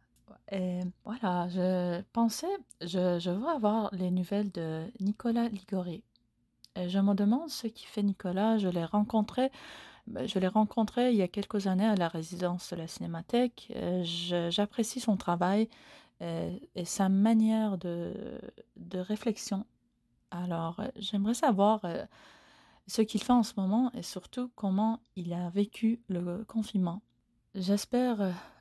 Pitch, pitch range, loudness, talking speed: 200 Hz, 180-225 Hz, -31 LUFS, 140 wpm